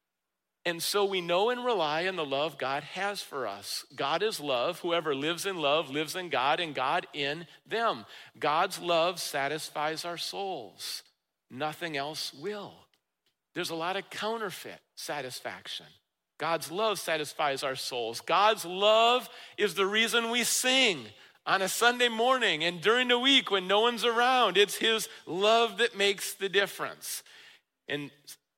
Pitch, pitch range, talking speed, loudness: 190 Hz, 155-220 Hz, 155 wpm, -28 LUFS